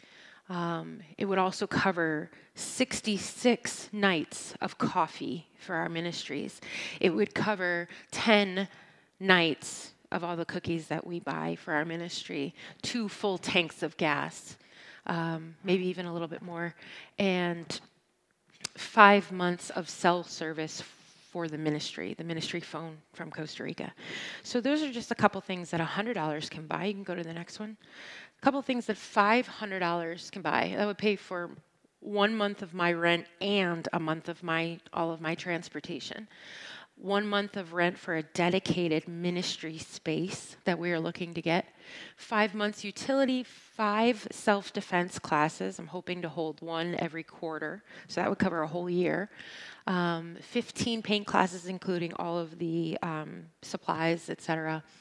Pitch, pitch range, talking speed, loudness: 175 Hz, 165-200 Hz, 160 wpm, -31 LUFS